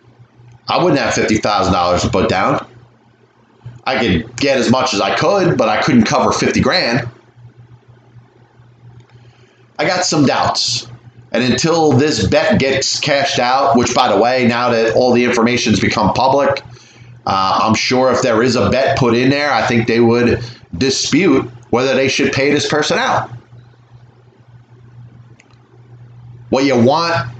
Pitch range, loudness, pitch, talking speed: 120-130 Hz, -14 LUFS, 120 Hz, 150 wpm